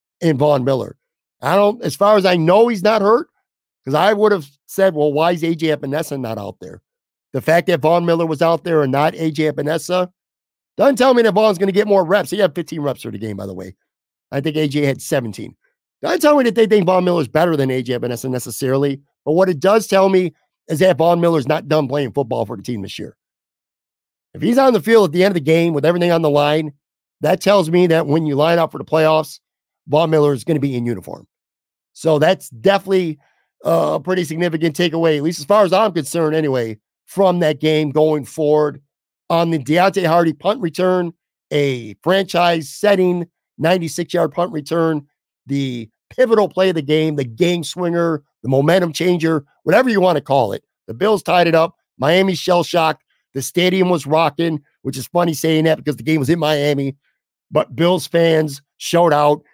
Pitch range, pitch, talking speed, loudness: 145-180 Hz, 165 Hz, 210 wpm, -16 LUFS